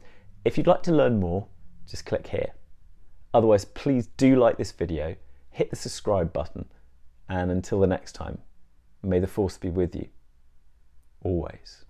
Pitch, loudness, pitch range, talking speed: 90 Hz, -26 LUFS, 70-100 Hz, 155 wpm